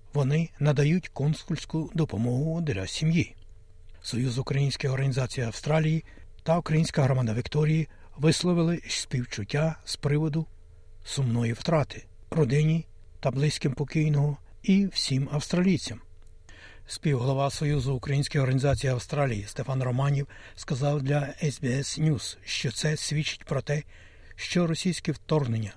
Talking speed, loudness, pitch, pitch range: 105 wpm, -27 LUFS, 140 Hz, 115-155 Hz